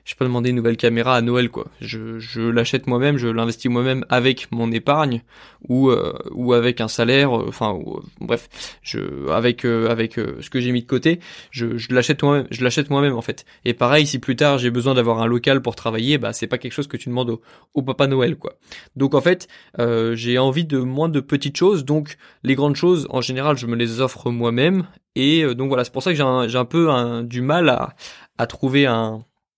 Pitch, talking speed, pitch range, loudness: 125 Hz, 240 wpm, 120-140 Hz, -19 LUFS